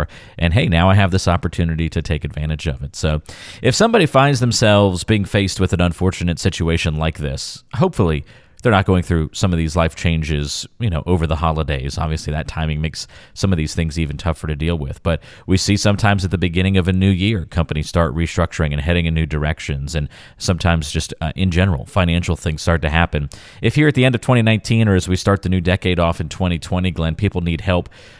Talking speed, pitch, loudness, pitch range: 220 wpm, 85 Hz, -18 LUFS, 80-95 Hz